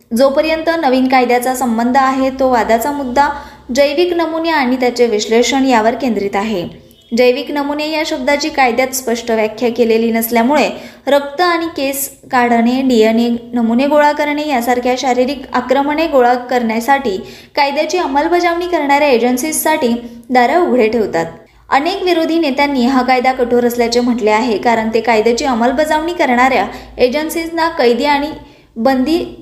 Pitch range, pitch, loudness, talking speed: 240-295 Hz, 260 Hz, -13 LUFS, 125 wpm